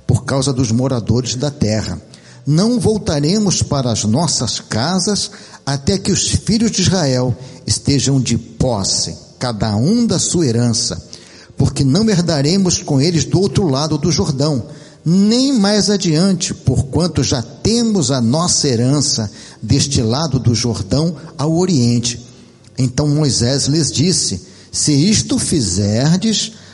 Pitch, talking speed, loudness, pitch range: 140 Hz, 130 wpm, -15 LUFS, 120-175 Hz